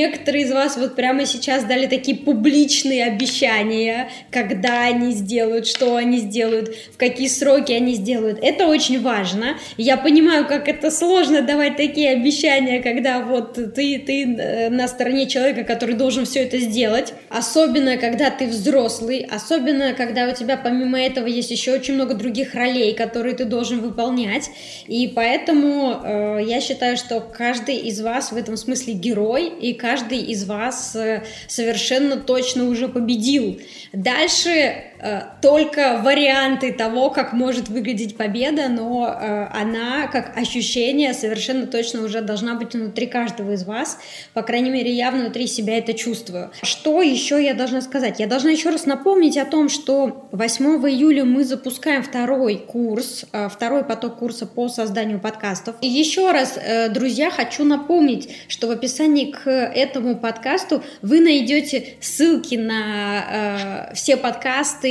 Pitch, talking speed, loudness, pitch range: 250 Hz, 145 wpm, -19 LUFS, 235-275 Hz